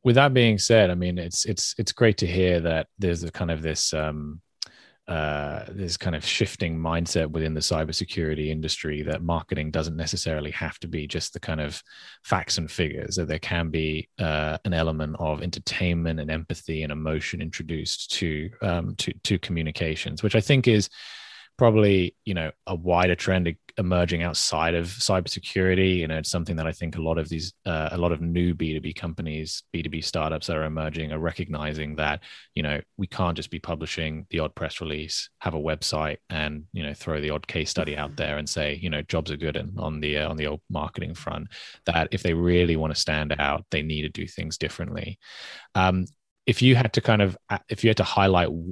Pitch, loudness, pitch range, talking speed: 85 Hz, -26 LUFS, 80-90 Hz, 210 wpm